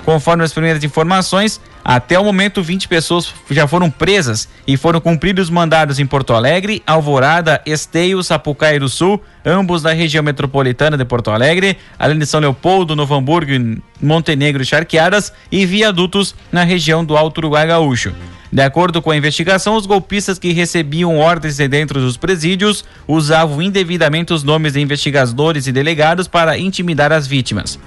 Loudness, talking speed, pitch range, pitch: -13 LUFS, 160 wpm, 145-175 Hz, 160 Hz